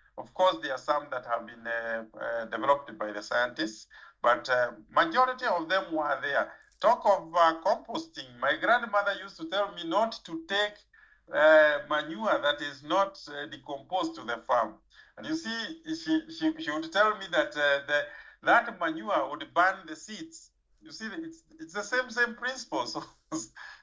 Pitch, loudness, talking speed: 195 Hz, -29 LUFS, 180 wpm